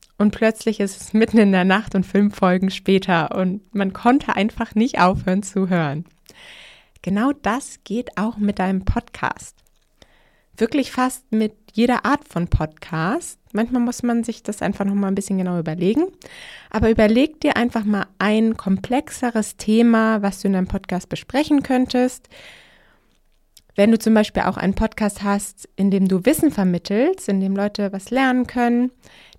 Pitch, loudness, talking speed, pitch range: 210 Hz, -20 LUFS, 160 wpm, 195-240 Hz